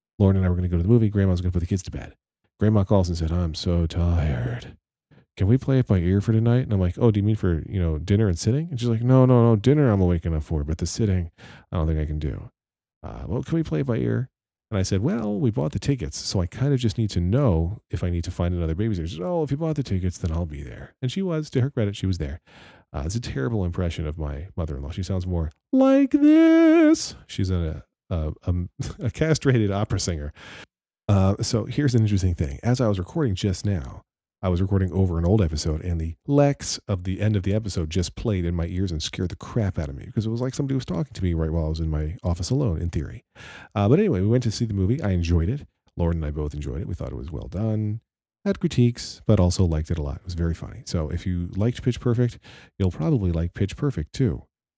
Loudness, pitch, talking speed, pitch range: -24 LUFS, 95 Hz, 270 wpm, 85-120 Hz